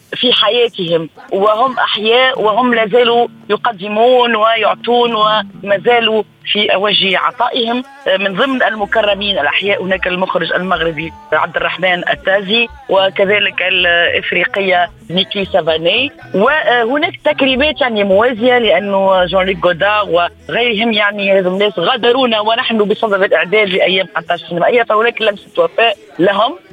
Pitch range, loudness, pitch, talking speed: 190-235 Hz, -12 LUFS, 205 Hz, 110 wpm